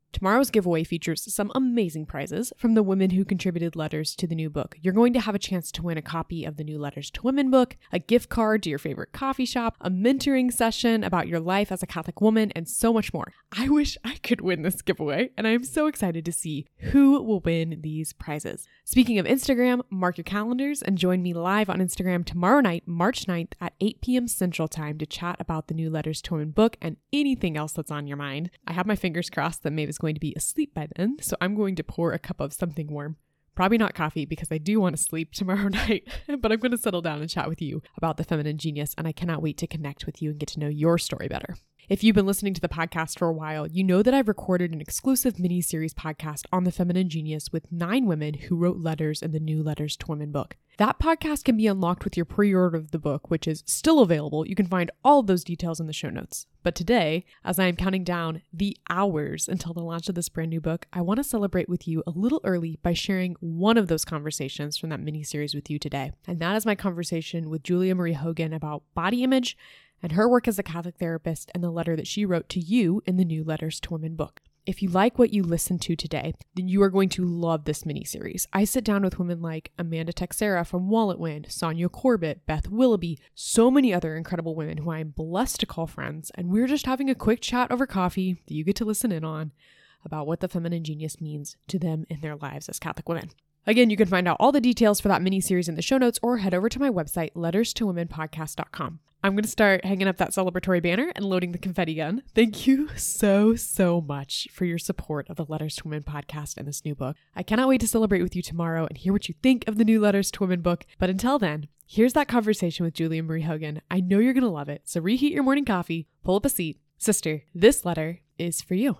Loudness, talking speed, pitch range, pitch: -25 LUFS, 250 wpm, 160-210 Hz, 175 Hz